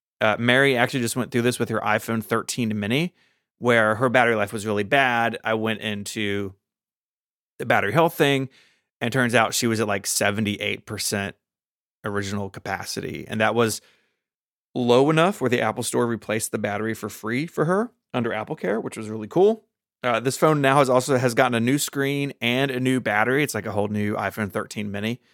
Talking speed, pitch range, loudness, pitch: 195 wpm, 105-130 Hz, -23 LUFS, 115 Hz